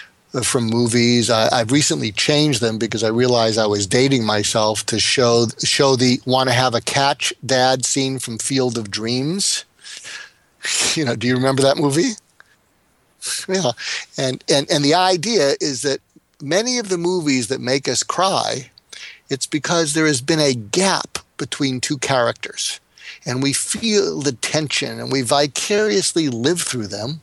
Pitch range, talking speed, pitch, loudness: 120-155 Hz, 160 wpm, 135 Hz, -18 LUFS